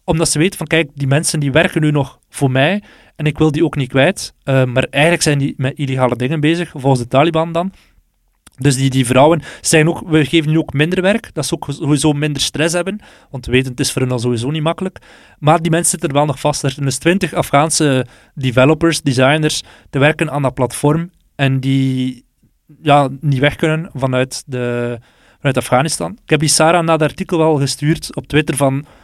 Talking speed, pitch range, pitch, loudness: 215 wpm, 135-160 Hz, 150 Hz, -15 LUFS